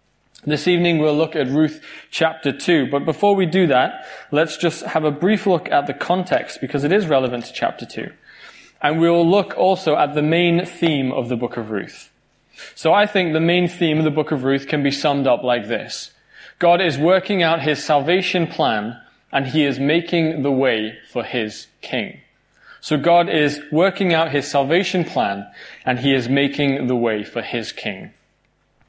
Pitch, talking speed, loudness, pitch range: 155 Hz, 190 wpm, -19 LUFS, 140-170 Hz